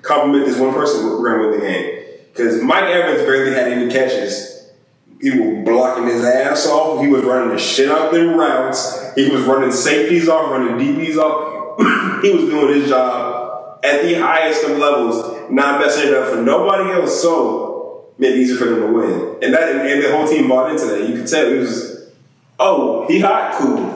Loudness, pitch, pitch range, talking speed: -15 LUFS, 145 Hz, 130-170 Hz, 210 wpm